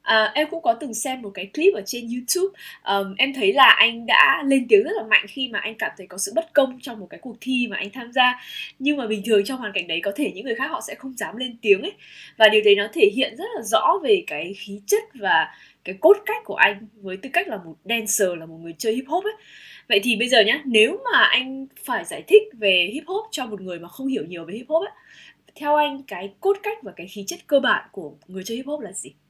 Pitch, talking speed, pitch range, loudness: 245 Hz, 280 wpm, 205-305 Hz, -21 LUFS